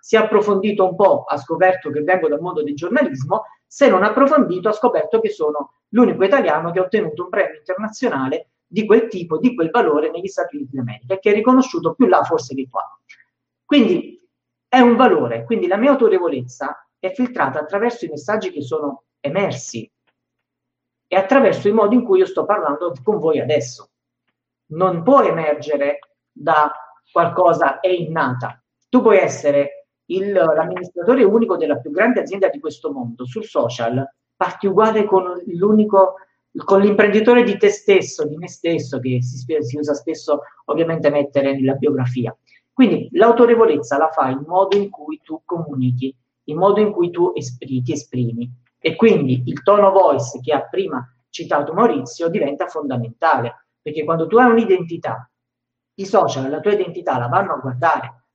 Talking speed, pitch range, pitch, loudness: 165 wpm, 140-210 Hz, 170 Hz, -17 LUFS